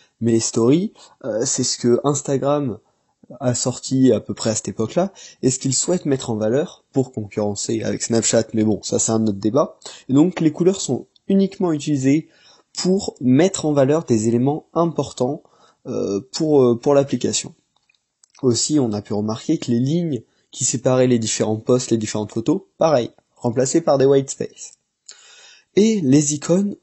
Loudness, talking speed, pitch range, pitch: -19 LUFS, 175 wpm, 115-150 Hz, 130 Hz